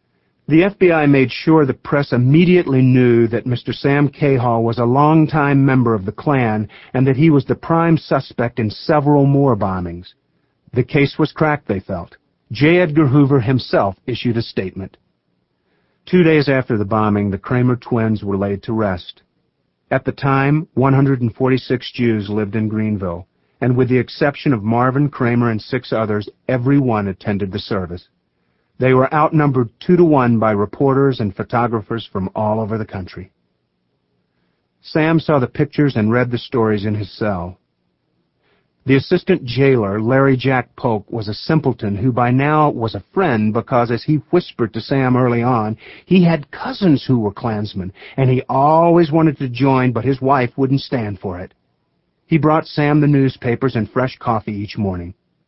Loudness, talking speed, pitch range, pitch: -16 LUFS, 170 wpm, 110-140 Hz, 125 Hz